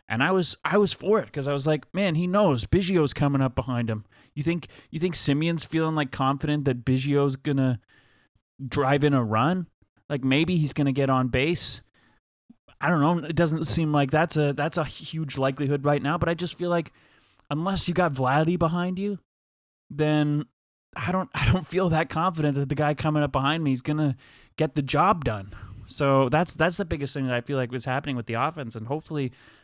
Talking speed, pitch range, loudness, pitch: 215 wpm, 130-160 Hz, -25 LUFS, 145 Hz